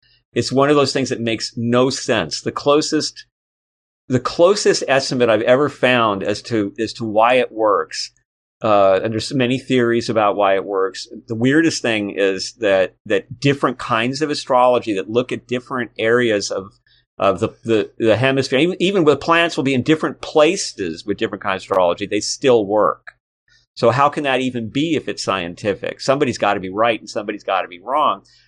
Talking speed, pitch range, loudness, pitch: 190 wpm, 110-140 Hz, -18 LUFS, 120 Hz